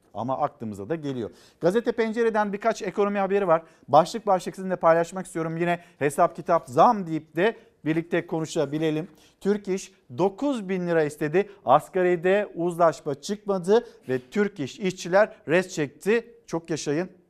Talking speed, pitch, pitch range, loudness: 140 wpm, 175 Hz, 160-200 Hz, -25 LUFS